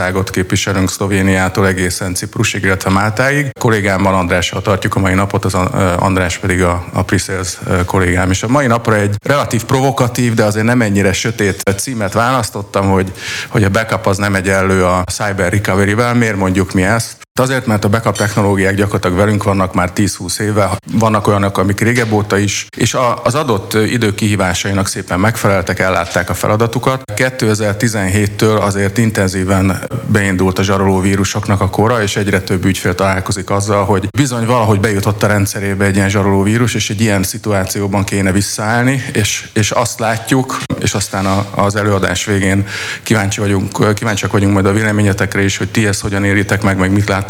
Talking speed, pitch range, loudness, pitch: 170 wpm, 95-110 Hz, -14 LUFS, 100 Hz